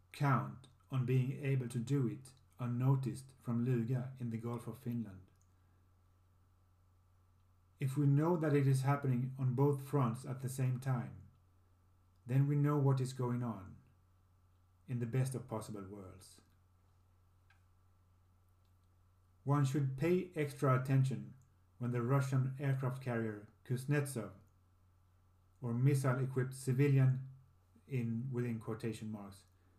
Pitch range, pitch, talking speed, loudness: 90-130 Hz, 120 Hz, 125 wpm, -37 LUFS